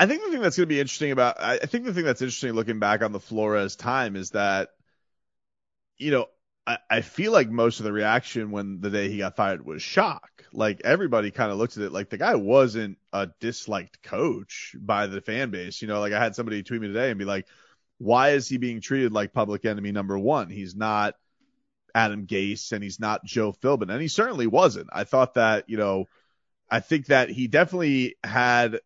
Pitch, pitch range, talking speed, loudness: 110 Hz, 100-125 Hz, 220 wpm, -25 LUFS